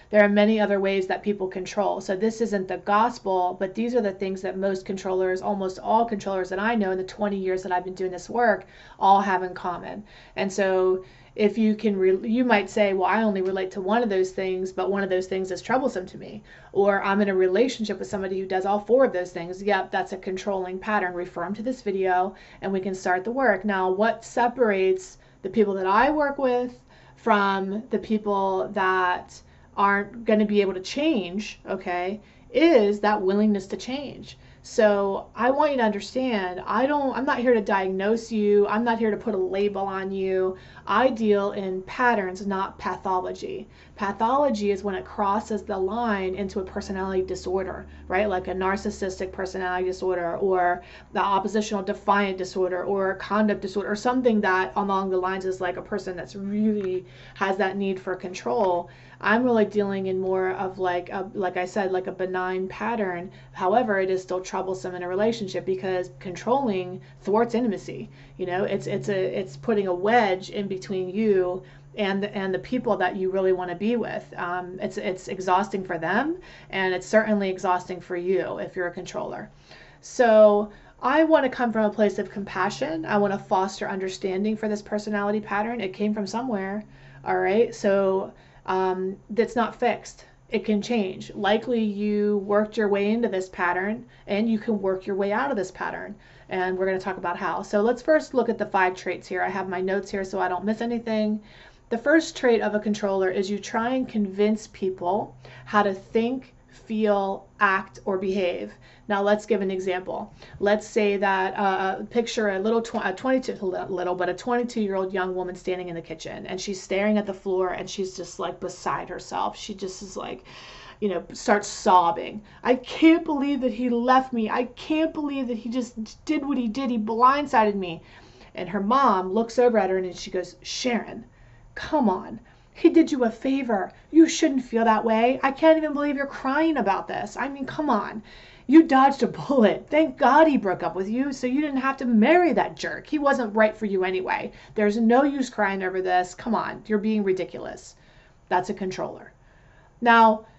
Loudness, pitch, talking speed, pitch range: -24 LUFS, 200 Hz, 200 wpm, 185-225 Hz